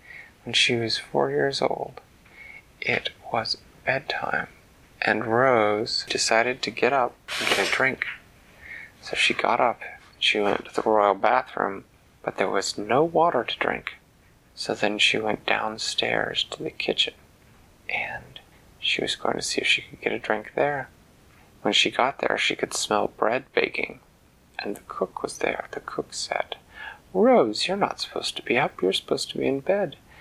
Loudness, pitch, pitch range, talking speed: -24 LUFS, 110 Hz, 105-125 Hz, 175 wpm